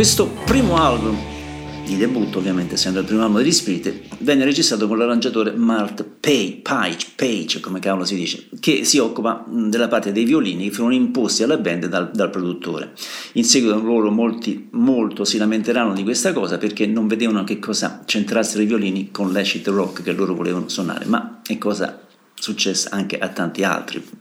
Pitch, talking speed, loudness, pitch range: 105 Hz, 175 wpm, -19 LUFS, 95-110 Hz